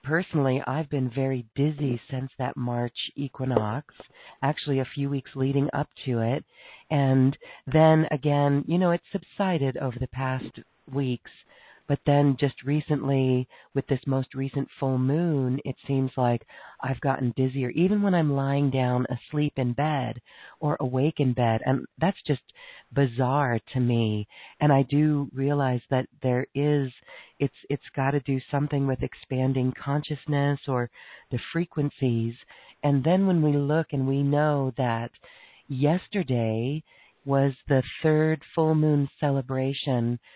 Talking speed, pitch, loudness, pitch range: 145 wpm, 135 Hz, -26 LUFS, 130-145 Hz